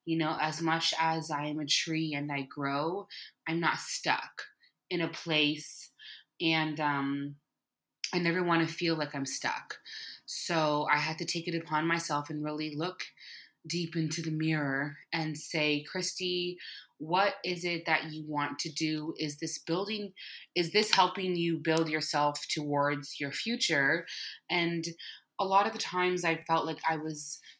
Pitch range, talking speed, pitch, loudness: 150-170 Hz, 165 wpm, 160 Hz, -31 LUFS